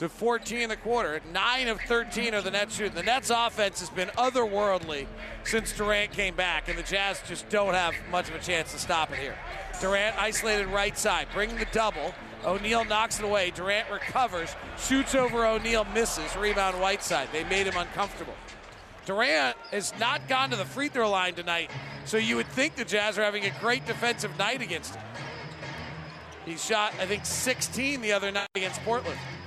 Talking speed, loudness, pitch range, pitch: 190 wpm, -28 LUFS, 190-230 Hz, 210 Hz